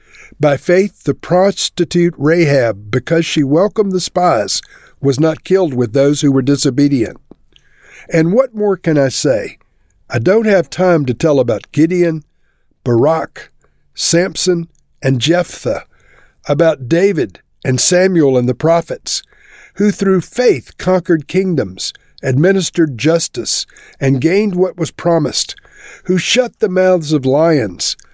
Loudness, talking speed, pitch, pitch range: -14 LUFS, 130 wpm, 170 Hz, 145-185 Hz